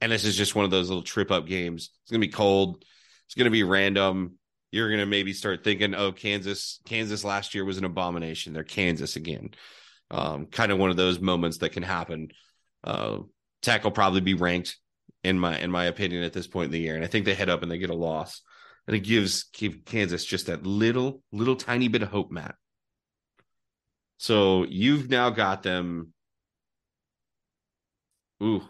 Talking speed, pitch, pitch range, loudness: 200 wpm, 95 Hz, 90-105 Hz, -26 LUFS